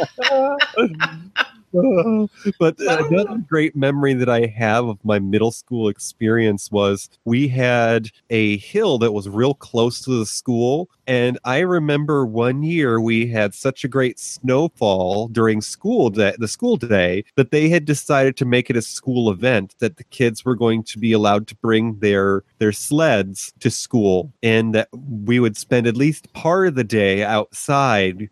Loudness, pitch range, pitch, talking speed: -19 LUFS, 110-140 Hz, 120 Hz, 165 wpm